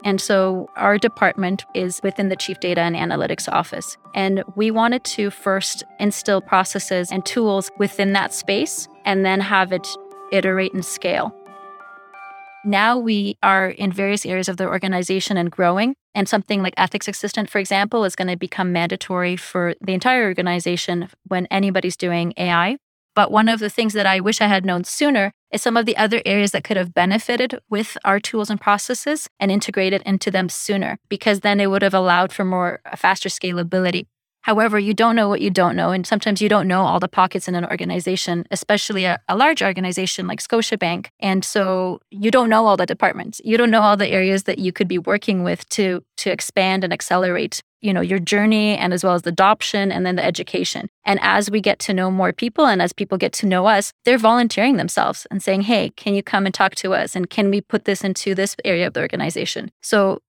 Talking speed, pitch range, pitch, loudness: 210 wpm, 185-210 Hz, 195 Hz, -19 LUFS